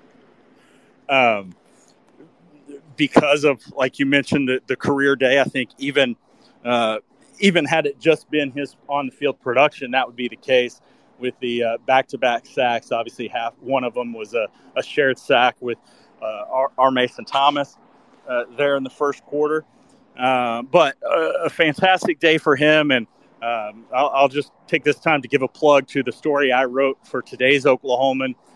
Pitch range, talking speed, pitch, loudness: 125-150 Hz, 180 wpm, 140 Hz, -19 LUFS